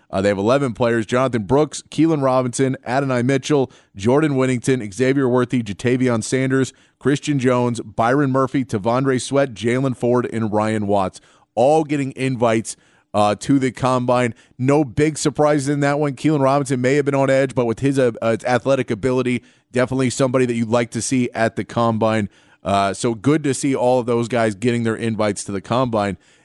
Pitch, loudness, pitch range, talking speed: 125 Hz, -19 LUFS, 115-135 Hz, 185 wpm